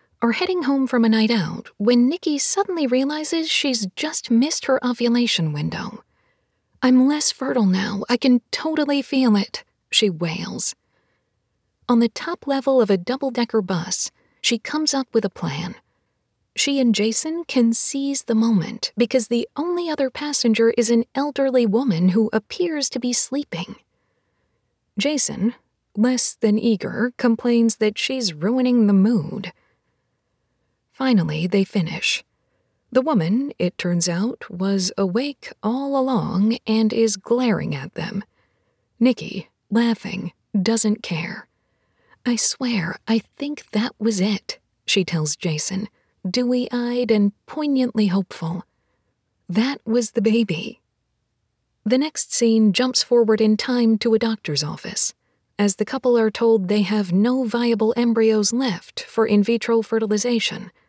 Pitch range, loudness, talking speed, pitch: 205-255 Hz, -20 LUFS, 140 wpm, 230 Hz